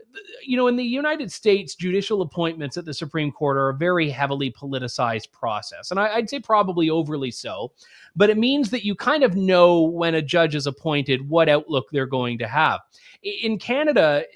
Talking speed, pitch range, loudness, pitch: 190 wpm, 145-220 Hz, -22 LUFS, 170 Hz